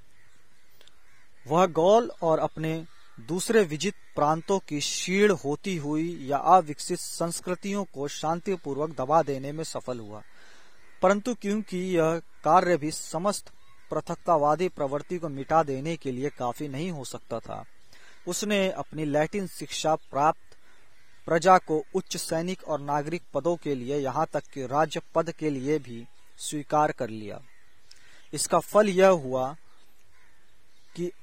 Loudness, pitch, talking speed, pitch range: -27 LUFS, 160 Hz, 135 wpm, 145-180 Hz